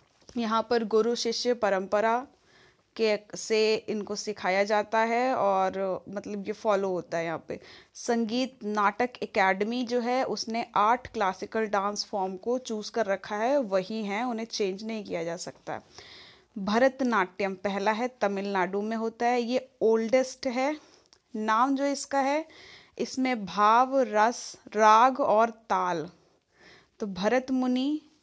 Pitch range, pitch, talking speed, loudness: 200-250 Hz, 220 Hz, 140 wpm, -27 LUFS